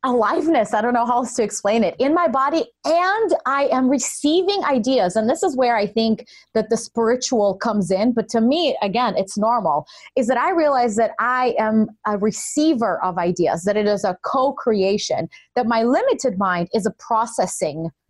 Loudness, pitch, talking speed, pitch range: -19 LUFS, 235 Hz, 190 wpm, 210-270 Hz